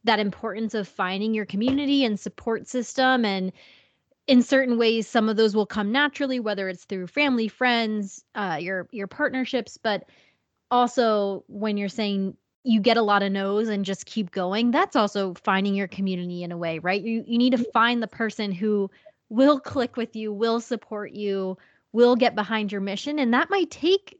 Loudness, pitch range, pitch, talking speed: -24 LUFS, 200-245 Hz, 220 Hz, 190 wpm